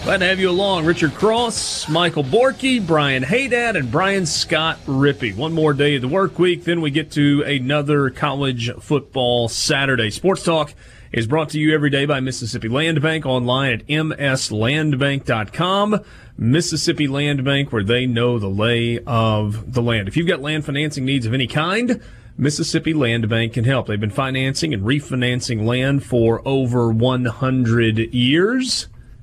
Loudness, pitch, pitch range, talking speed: -18 LUFS, 140 Hz, 120-160 Hz, 165 wpm